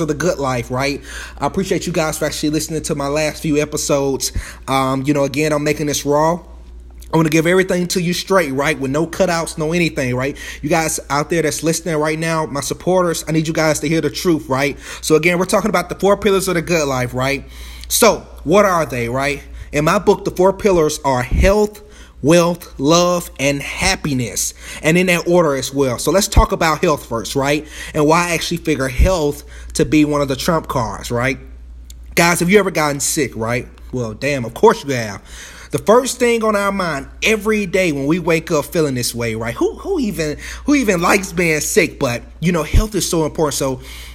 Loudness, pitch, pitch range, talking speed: -17 LUFS, 155 Hz, 140-175 Hz, 220 wpm